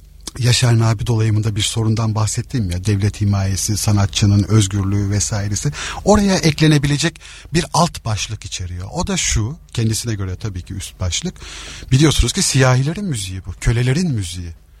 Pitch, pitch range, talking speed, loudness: 110 Hz, 100-135 Hz, 140 wpm, -17 LUFS